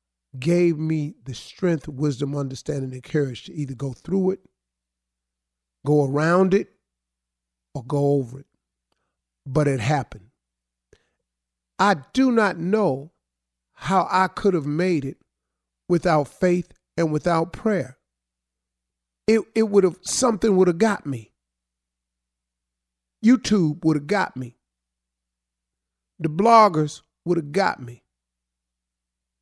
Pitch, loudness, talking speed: 135 Hz, -22 LUFS, 120 wpm